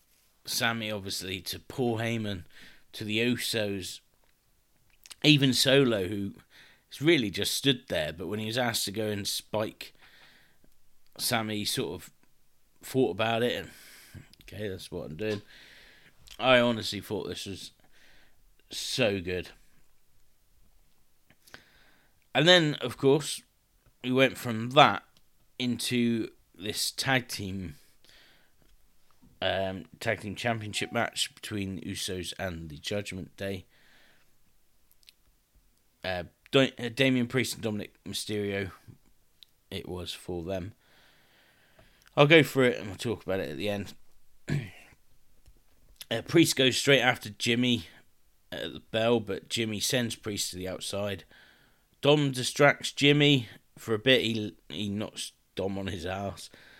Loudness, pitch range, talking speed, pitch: -28 LUFS, 95-125 Hz, 125 wpm, 110 Hz